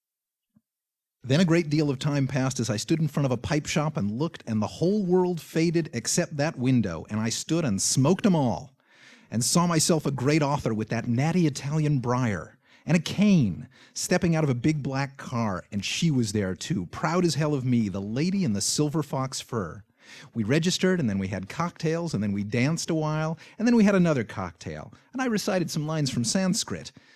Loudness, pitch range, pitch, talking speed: -26 LUFS, 115-170 Hz, 145 Hz, 215 wpm